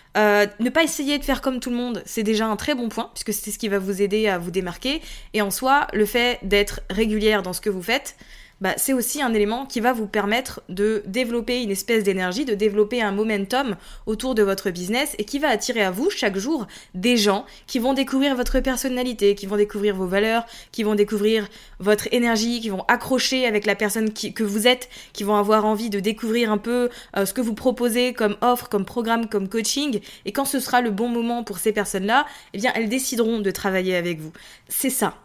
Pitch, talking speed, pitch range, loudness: 220 Hz, 230 wpm, 205-245 Hz, -22 LUFS